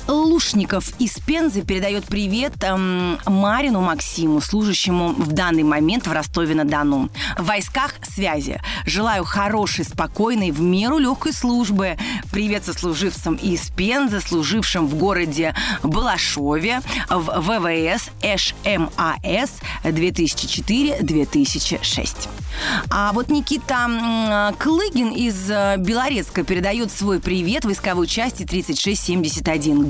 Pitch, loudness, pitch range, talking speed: 195 Hz, -19 LUFS, 170-230 Hz, 95 wpm